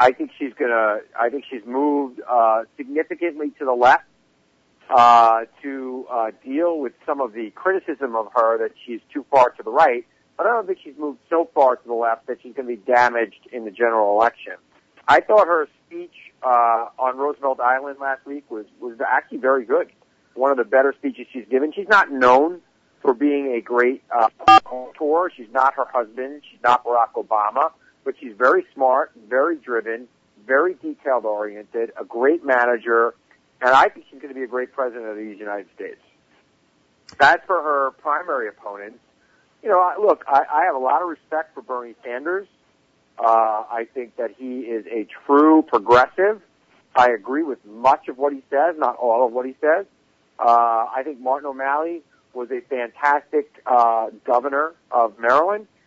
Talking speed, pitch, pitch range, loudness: 185 wpm, 130 Hz, 115-155 Hz, -20 LUFS